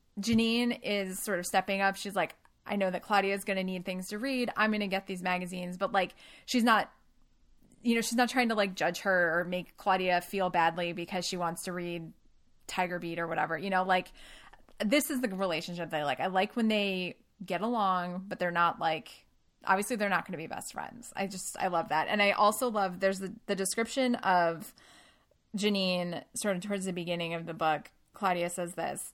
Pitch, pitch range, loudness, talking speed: 190 Hz, 175-205 Hz, -31 LUFS, 220 wpm